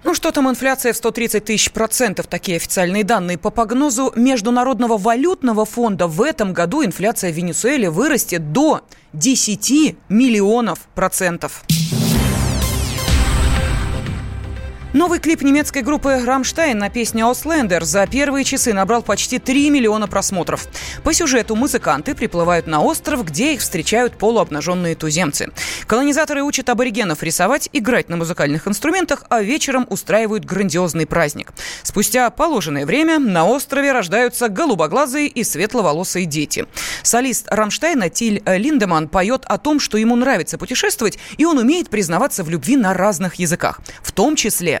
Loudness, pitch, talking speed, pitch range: -17 LUFS, 225 Hz, 135 wpm, 180-265 Hz